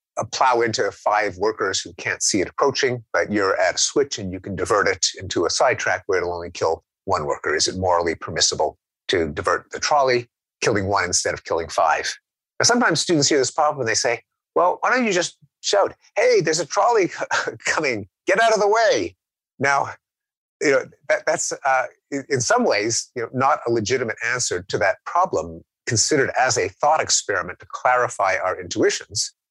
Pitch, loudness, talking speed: 150 Hz, -20 LUFS, 195 wpm